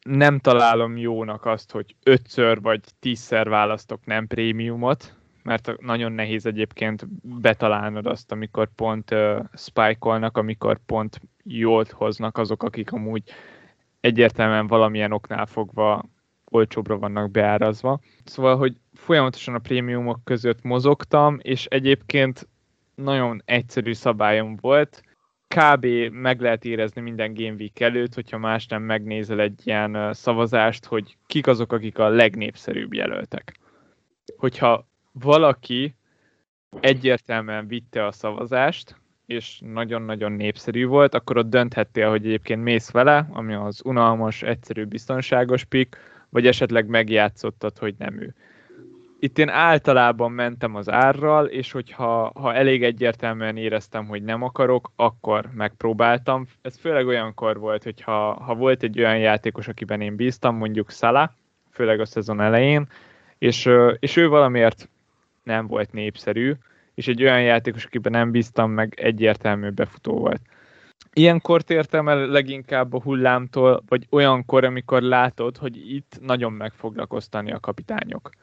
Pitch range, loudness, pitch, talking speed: 110-130 Hz, -21 LUFS, 115 Hz, 130 wpm